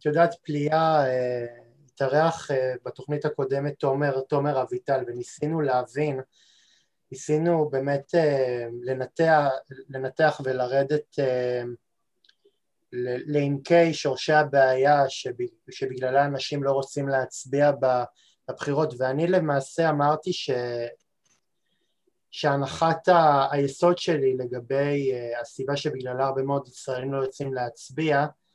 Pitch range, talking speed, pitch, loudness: 130-150 Hz, 85 wpm, 140 Hz, -25 LUFS